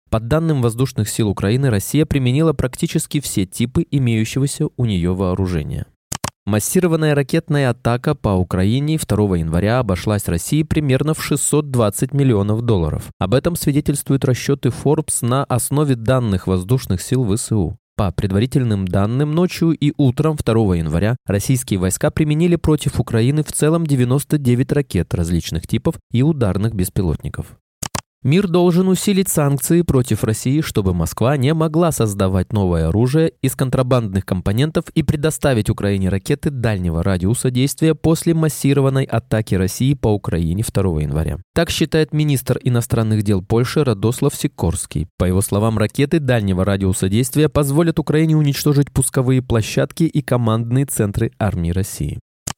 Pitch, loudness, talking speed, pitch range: 125 Hz, -18 LUFS, 135 wpm, 100-150 Hz